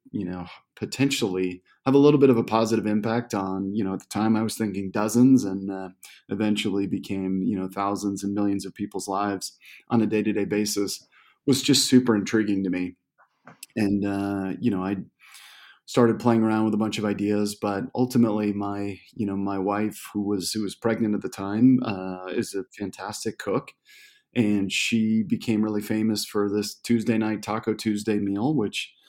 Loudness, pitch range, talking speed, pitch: -25 LUFS, 100-115 Hz, 185 wpm, 105 Hz